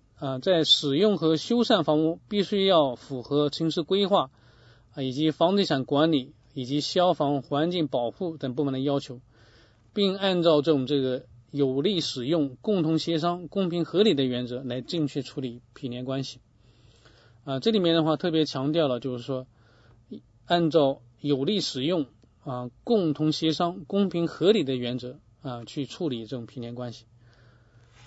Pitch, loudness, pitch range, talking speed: 140 Hz, -26 LUFS, 125-165 Hz, 240 characters per minute